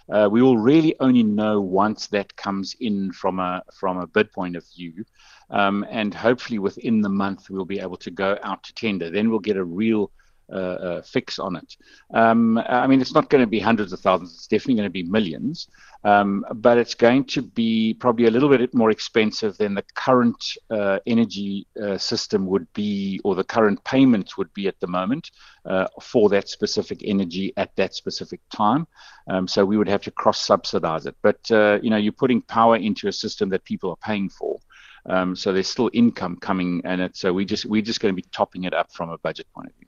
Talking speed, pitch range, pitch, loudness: 220 wpm, 95-115 Hz, 105 Hz, -22 LUFS